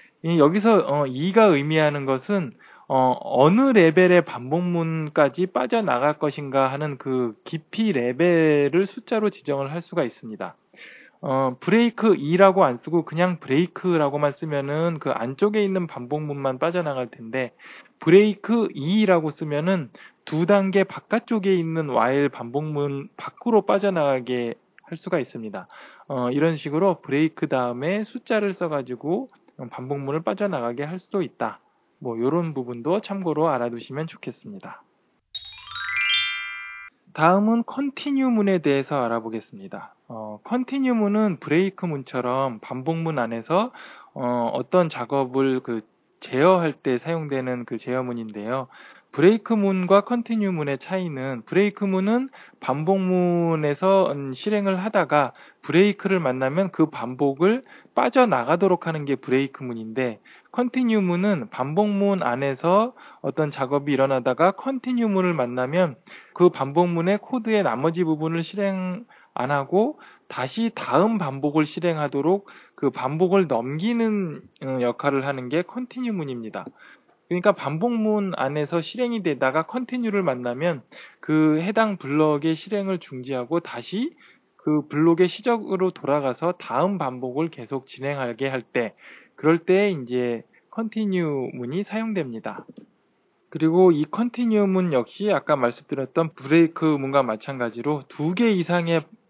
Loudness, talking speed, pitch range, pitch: -23 LUFS, 295 characters per minute, 135-195 Hz, 165 Hz